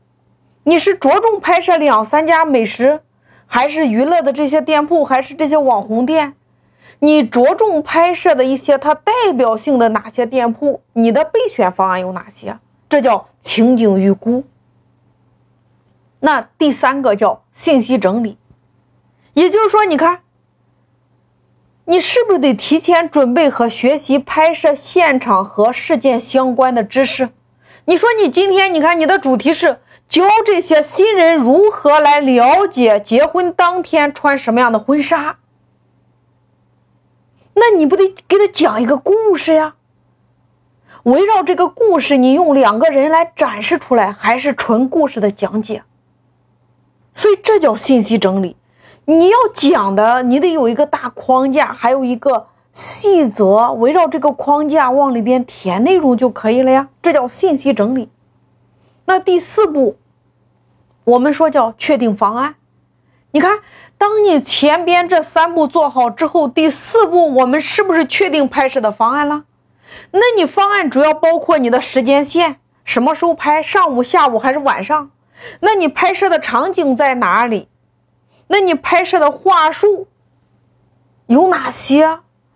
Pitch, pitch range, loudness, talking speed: 295 Hz, 255-345 Hz, -13 LUFS, 220 characters per minute